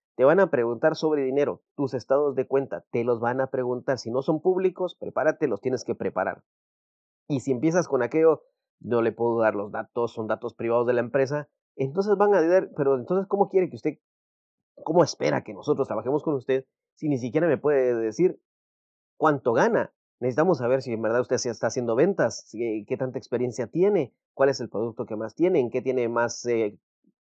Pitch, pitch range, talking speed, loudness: 130 Hz, 120-155 Hz, 200 wpm, -25 LUFS